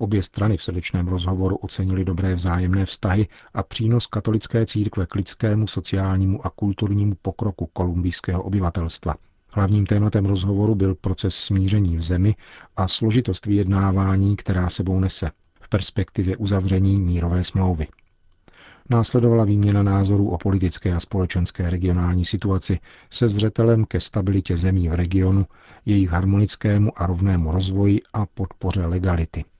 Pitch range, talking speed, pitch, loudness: 90-105 Hz, 130 wpm, 95 Hz, -21 LUFS